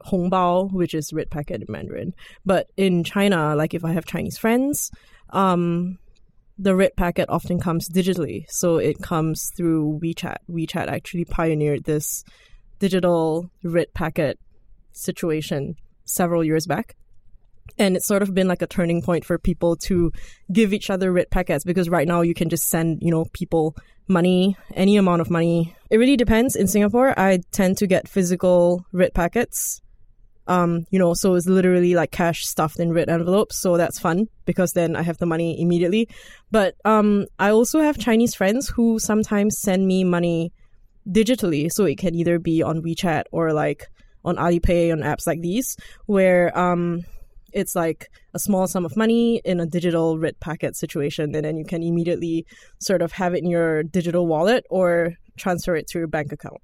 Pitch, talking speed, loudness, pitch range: 175 Hz, 180 wpm, -21 LUFS, 165-190 Hz